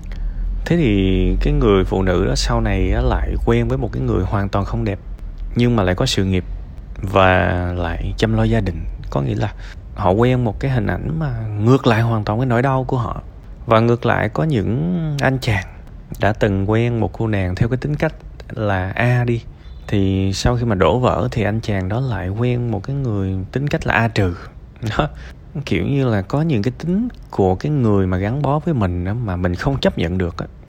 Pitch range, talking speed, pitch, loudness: 95-125 Hz, 225 wpm, 110 Hz, -19 LUFS